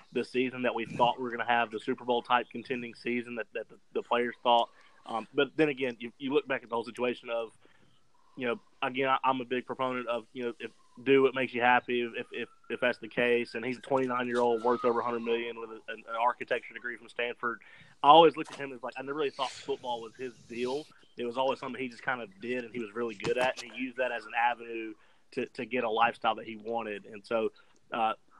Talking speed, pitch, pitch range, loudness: 260 wpm, 120 Hz, 120-130 Hz, -31 LUFS